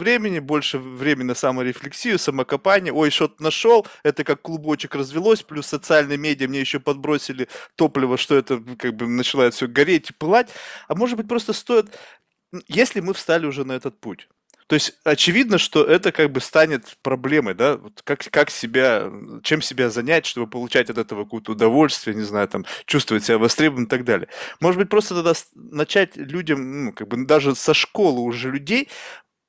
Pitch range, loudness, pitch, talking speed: 130-165 Hz, -20 LUFS, 150 Hz, 175 wpm